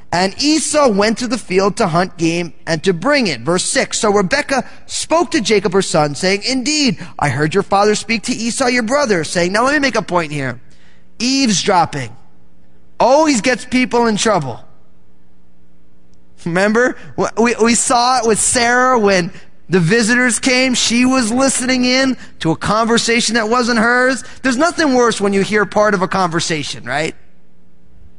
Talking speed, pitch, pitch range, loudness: 170 wpm, 210 Hz, 170-250 Hz, -14 LUFS